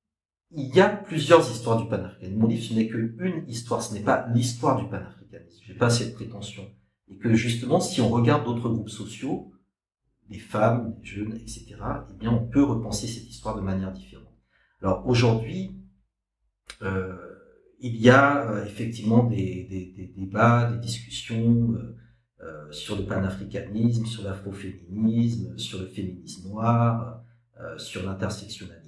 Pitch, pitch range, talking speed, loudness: 115 Hz, 100-120 Hz, 155 wpm, -25 LUFS